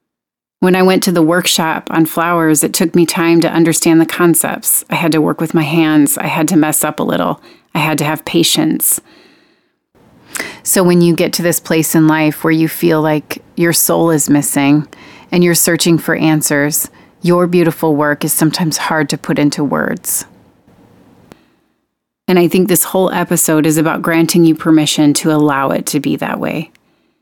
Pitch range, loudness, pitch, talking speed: 155-175 Hz, -12 LUFS, 165 Hz, 185 wpm